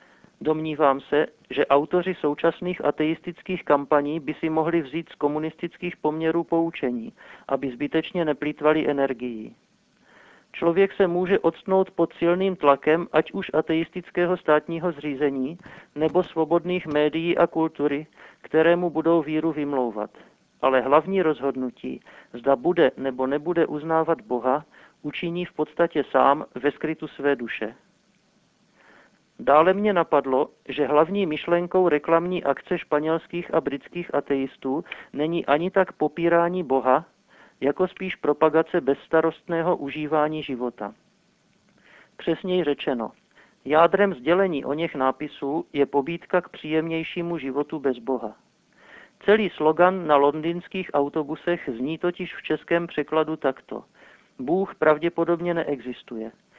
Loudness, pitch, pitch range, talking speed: -24 LUFS, 160 Hz, 145-175 Hz, 115 wpm